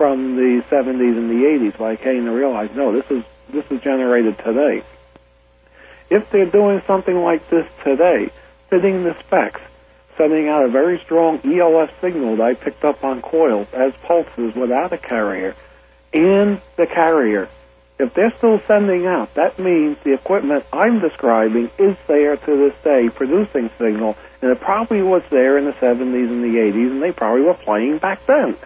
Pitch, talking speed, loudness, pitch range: 135 Hz, 175 wpm, -17 LUFS, 115-170 Hz